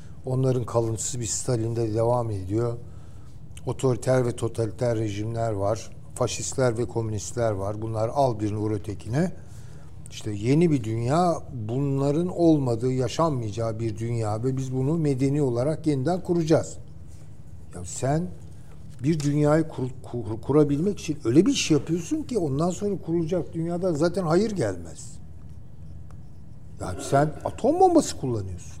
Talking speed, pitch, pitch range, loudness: 135 wpm, 125 Hz, 115-155 Hz, -25 LUFS